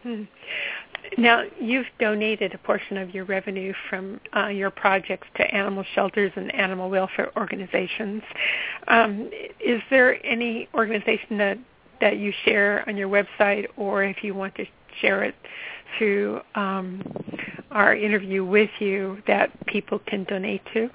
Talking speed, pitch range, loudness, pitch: 140 wpm, 195-220 Hz, -23 LUFS, 205 Hz